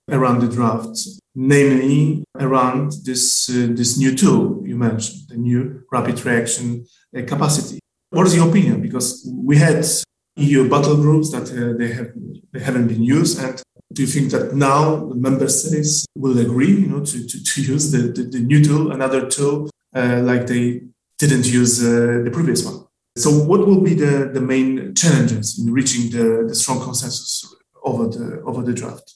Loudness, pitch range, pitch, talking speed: -17 LUFS, 120-150 Hz, 130 Hz, 180 wpm